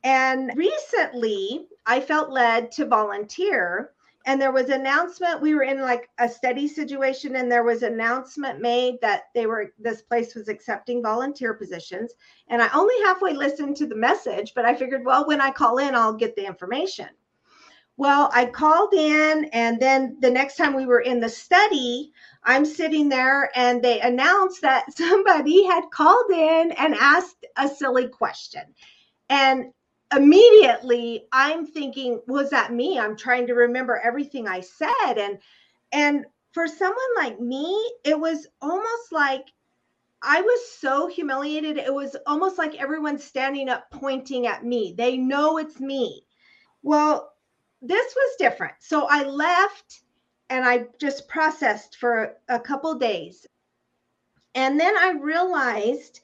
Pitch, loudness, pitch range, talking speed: 275 Hz, -21 LUFS, 245-315 Hz, 155 wpm